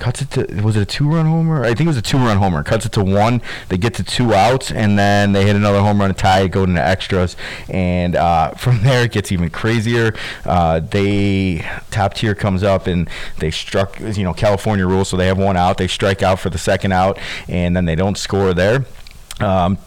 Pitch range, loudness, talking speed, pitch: 95-110 Hz, -16 LUFS, 230 wpm, 100 Hz